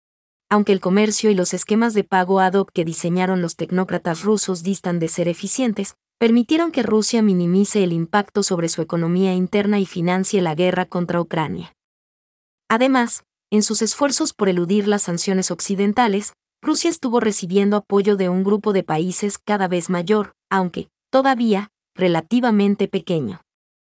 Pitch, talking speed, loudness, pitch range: 195 Hz, 150 wpm, -19 LUFS, 180-210 Hz